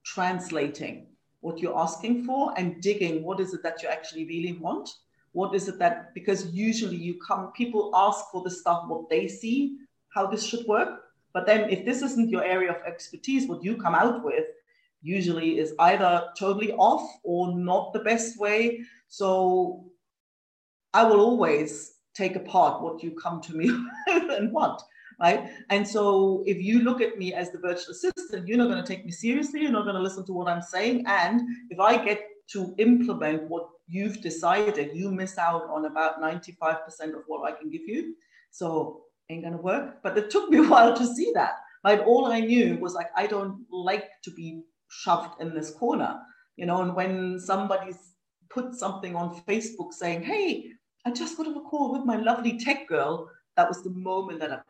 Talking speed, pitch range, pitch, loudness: 195 wpm, 170-235 Hz, 190 Hz, -26 LUFS